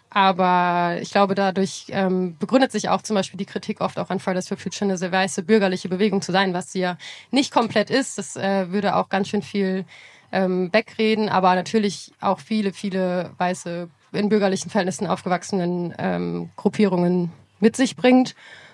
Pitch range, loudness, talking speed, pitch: 180-210 Hz, -22 LUFS, 165 wpm, 195 Hz